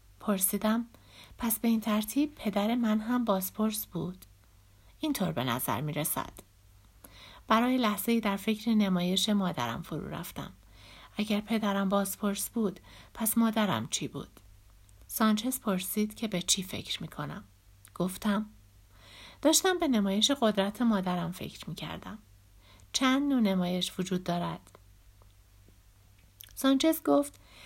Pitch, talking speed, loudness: 190 Hz, 120 wpm, -30 LUFS